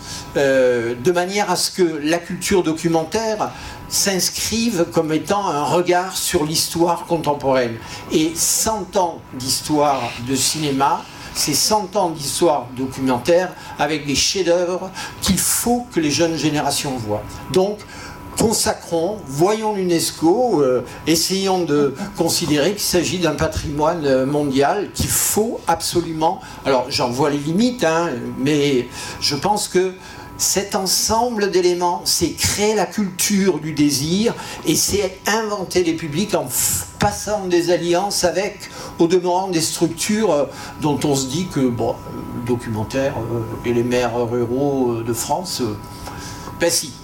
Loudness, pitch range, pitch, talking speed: -19 LUFS, 140-185 Hz, 165 Hz, 130 wpm